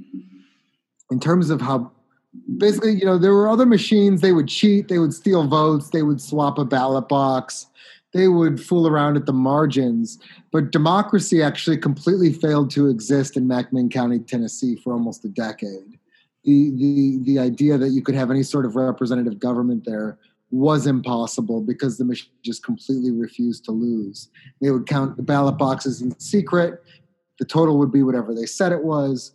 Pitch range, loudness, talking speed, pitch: 125-170 Hz, -19 LUFS, 180 wpm, 140 Hz